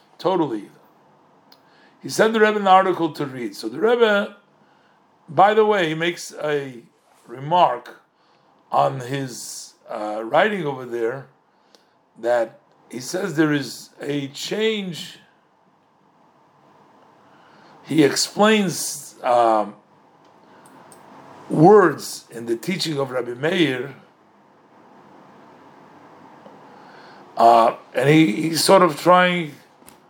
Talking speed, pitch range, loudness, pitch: 100 wpm, 125-185 Hz, -19 LUFS, 160 Hz